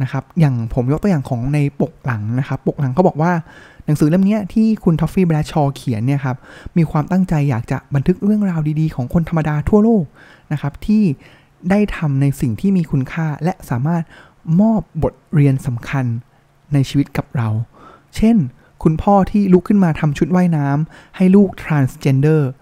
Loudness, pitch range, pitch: -17 LUFS, 140-180 Hz, 155 Hz